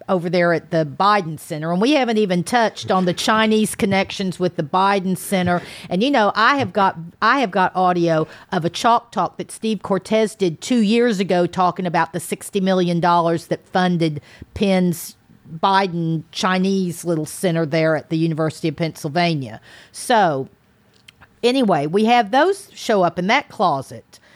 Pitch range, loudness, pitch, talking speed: 170-205 Hz, -19 LUFS, 185 Hz, 170 wpm